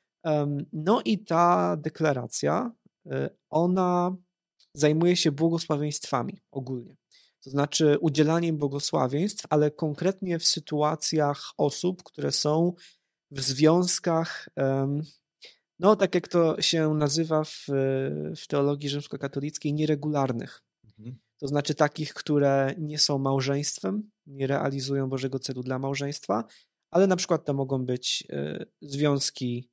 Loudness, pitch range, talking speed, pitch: -26 LUFS, 140-165 Hz, 105 wpm, 150 Hz